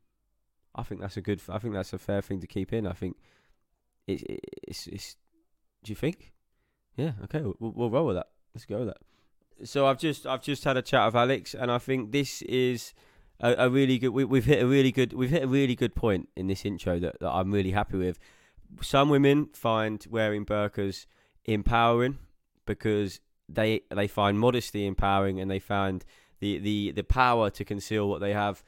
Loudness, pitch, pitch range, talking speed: -28 LUFS, 110 Hz, 100-130 Hz, 205 wpm